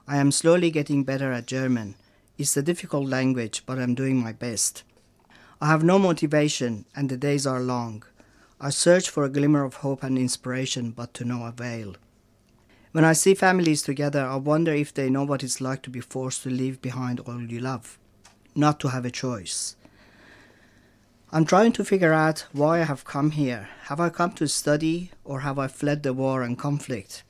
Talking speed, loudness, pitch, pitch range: 195 wpm, -24 LUFS, 135 Hz, 120-150 Hz